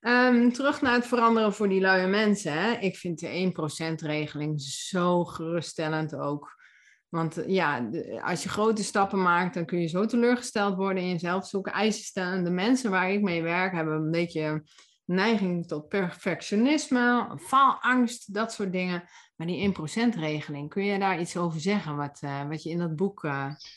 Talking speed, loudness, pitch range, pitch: 175 wpm, -27 LUFS, 160-205 Hz, 180 Hz